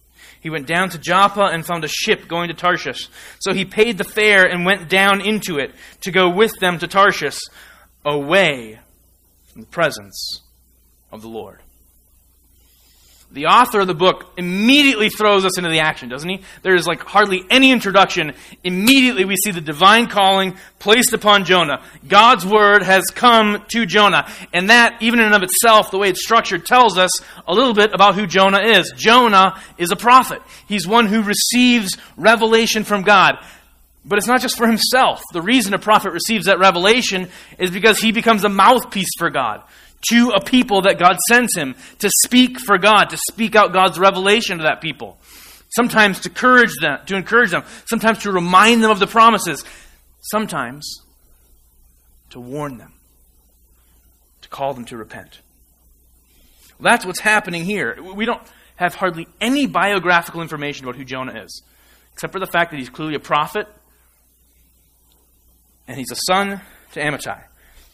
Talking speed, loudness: 170 wpm, -14 LUFS